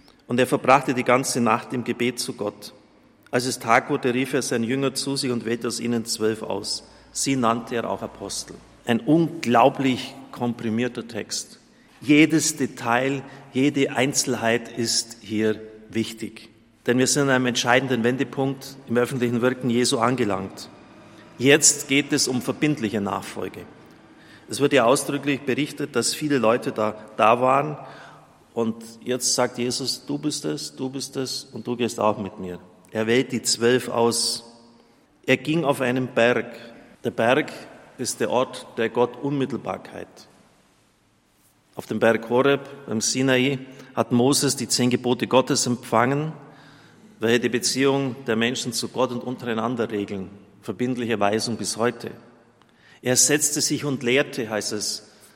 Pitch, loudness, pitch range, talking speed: 125 Hz, -23 LUFS, 115-135 Hz, 150 wpm